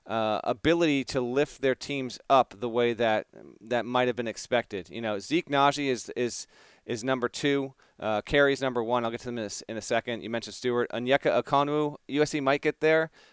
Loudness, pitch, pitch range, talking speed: -28 LUFS, 125 Hz, 115-140 Hz, 205 wpm